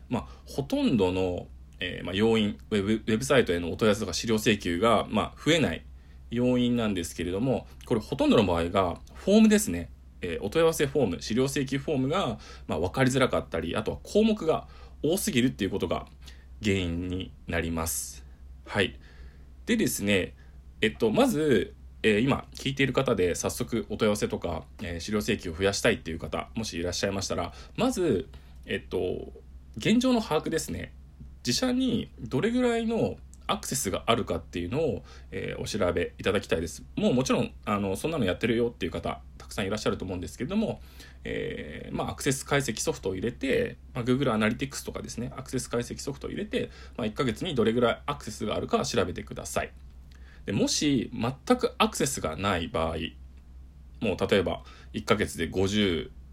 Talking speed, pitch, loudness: 405 characters per minute, 90 Hz, -28 LUFS